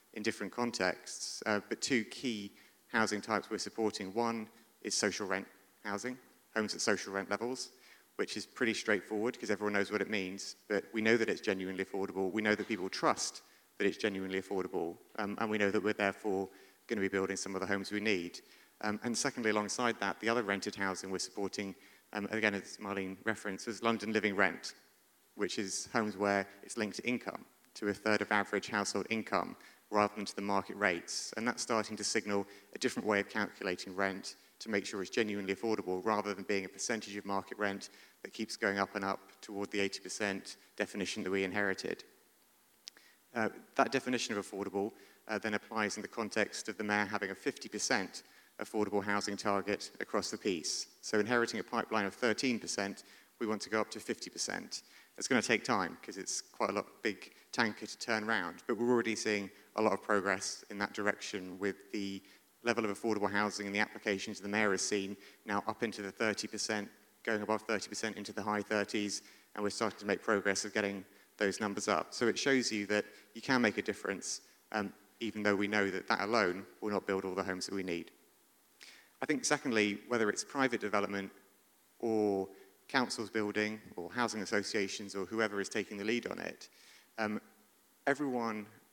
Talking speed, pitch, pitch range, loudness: 195 wpm, 105 Hz, 100-110 Hz, -36 LUFS